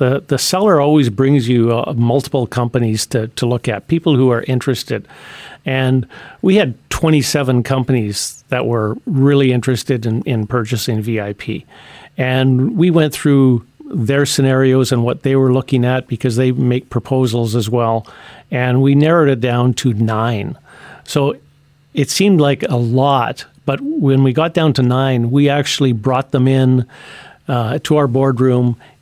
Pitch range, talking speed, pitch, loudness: 120-140 Hz, 160 wpm, 130 Hz, -15 LUFS